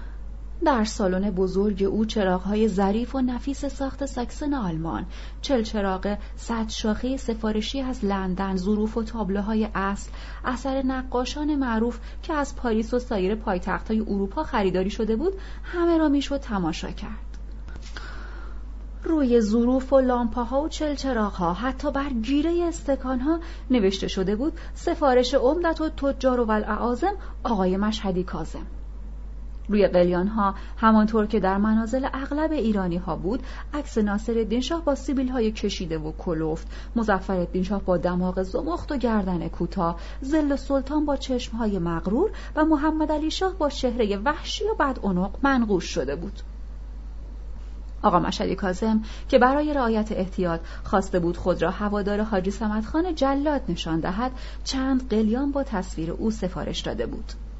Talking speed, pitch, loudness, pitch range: 140 wpm, 220 Hz, -25 LUFS, 190-270 Hz